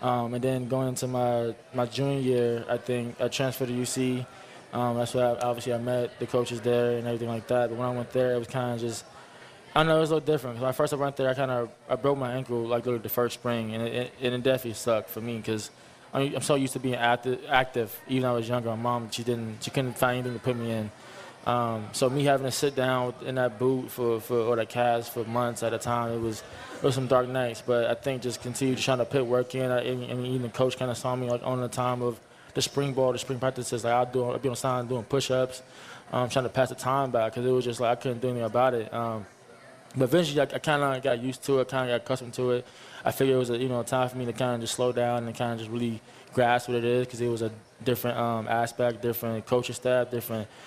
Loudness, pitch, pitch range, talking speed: -28 LUFS, 125 Hz, 120-130 Hz, 280 wpm